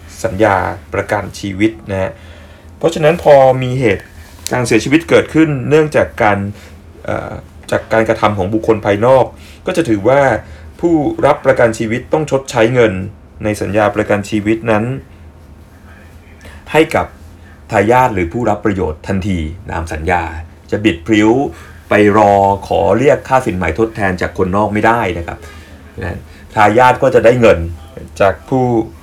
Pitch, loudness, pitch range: 100 Hz, -13 LUFS, 85-110 Hz